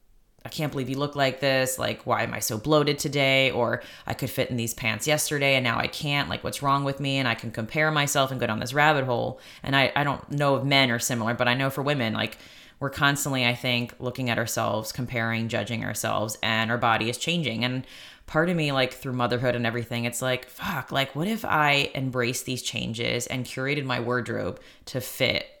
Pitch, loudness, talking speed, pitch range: 130 Hz, -25 LUFS, 225 wpm, 120-140 Hz